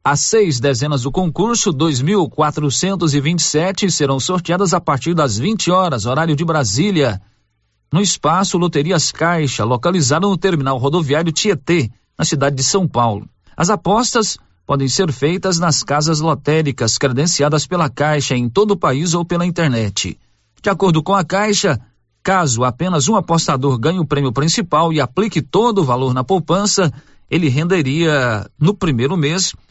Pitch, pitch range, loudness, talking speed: 155 Hz, 135-185 Hz, -16 LUFS, 145 wpm